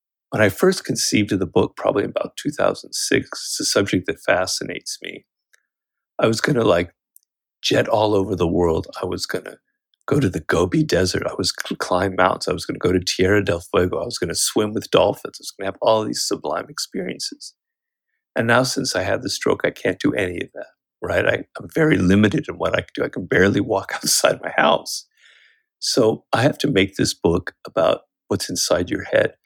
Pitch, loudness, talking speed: 110 Hz, -20 LUFS, 220 wpm